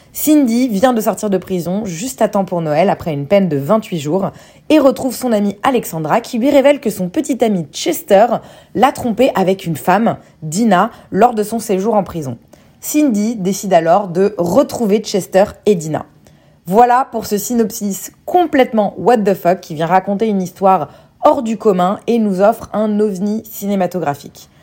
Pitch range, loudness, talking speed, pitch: 185-235 Hz, -15 LUFS, 175 wpm, 210 Hz